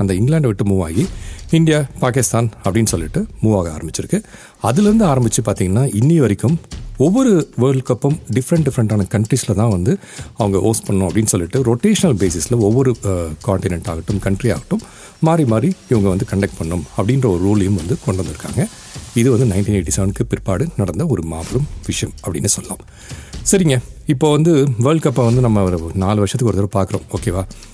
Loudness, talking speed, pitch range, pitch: -16 LUFS, 160 wpm, 100-135 Hz, 115 Hz